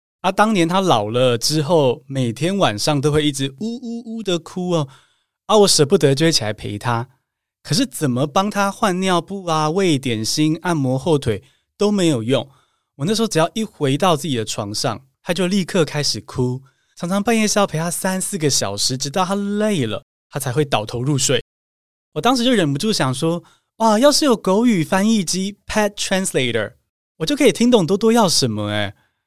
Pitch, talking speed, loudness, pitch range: 165 Hz, 295 characters per minute, -18 LUFS, 135-200 Hz